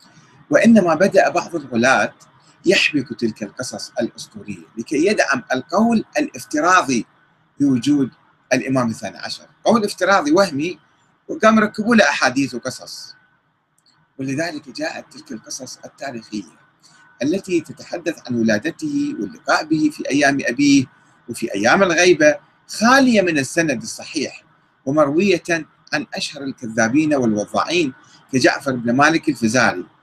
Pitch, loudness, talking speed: 170 Hz, -18 LUFS, 110 wpm